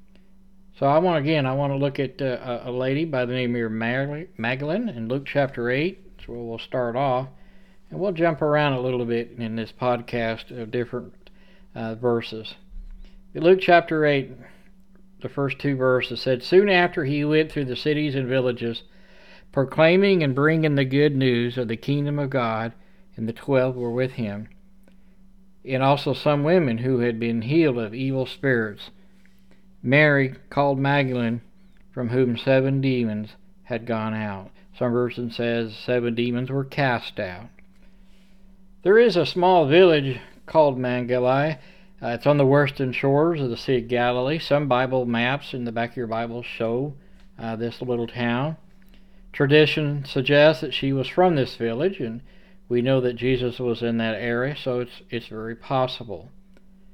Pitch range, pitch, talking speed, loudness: 120-170 Hz, 135 Hz, 165 wpm, -23 LUFS